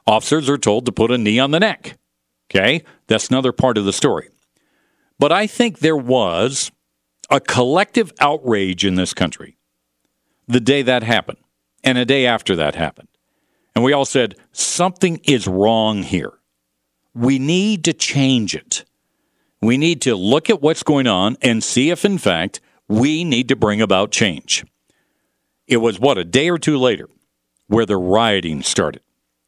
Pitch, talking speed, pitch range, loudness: 120 Hz, 165 wpm, 95-140 Hz, -17 LUFS